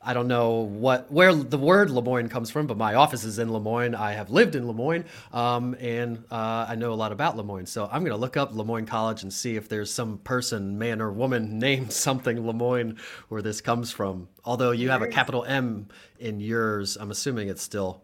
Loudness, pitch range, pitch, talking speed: -26 LUFS, 110-125 Hz, 115 Hz, 220 wpm